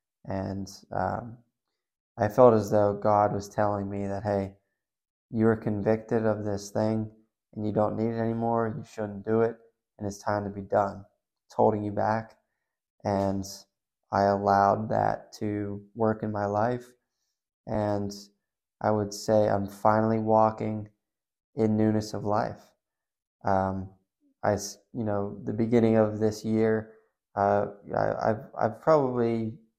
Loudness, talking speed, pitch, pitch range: -27 LUFS, 145 wpm, 105 Hz, 100-110 Hz